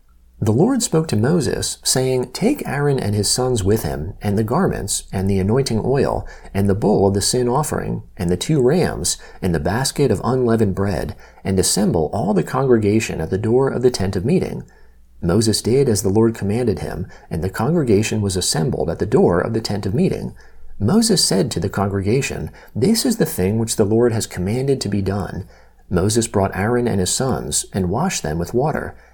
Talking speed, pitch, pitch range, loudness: 200 wpm, 110 Hz, 95-125 Hz, -19 LUFS